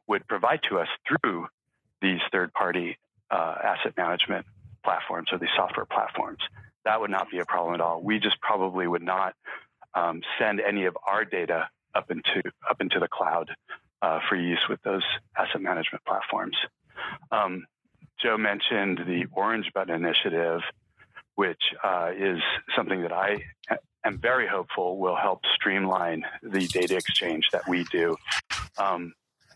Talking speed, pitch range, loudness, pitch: 150 wpm, 85-95 Hz, -27 LUFS, 95 Hz